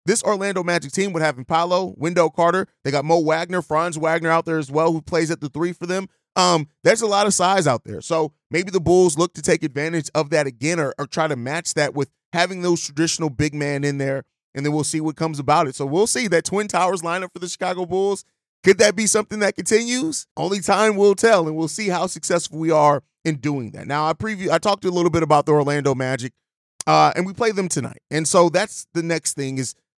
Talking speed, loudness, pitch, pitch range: 245 wpm, -20 LUFS, 165 Hz, 150-185 Hz